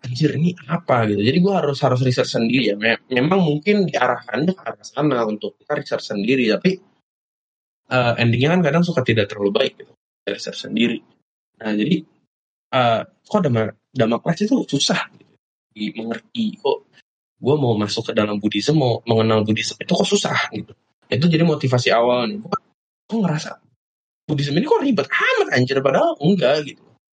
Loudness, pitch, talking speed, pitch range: -19 LUFS, 140 Hz, 160 wpm, 115-180 Hz